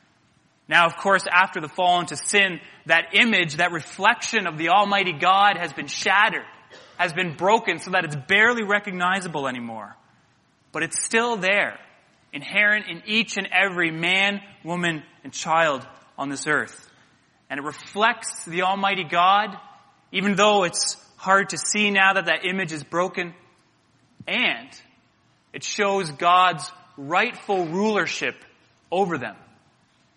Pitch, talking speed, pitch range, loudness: 180 Hz, 140 wpm, 165-200 Hz, -21 LUFS